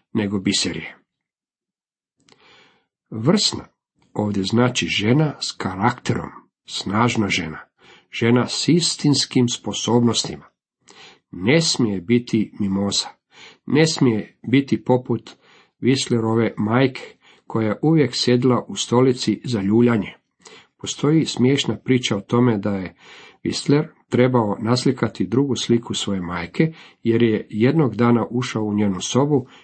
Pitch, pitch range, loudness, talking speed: 120 Hz, 105-130 Hz, -20 LUFS, 110 wpm